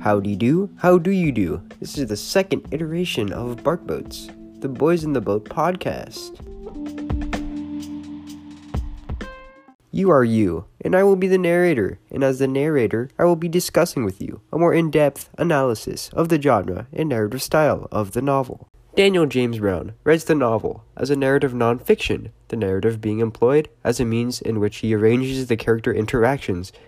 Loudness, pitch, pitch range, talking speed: -20 LUFS, 130 Hz, 110-165 Hz, 175 wpm